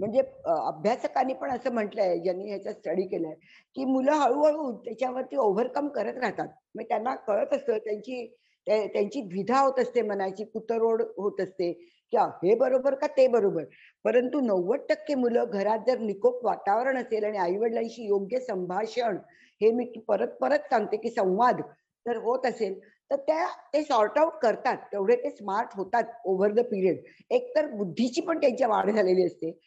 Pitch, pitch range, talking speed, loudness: 235 Hz, 205-265 Hz, 160 wpm, -27 LUFS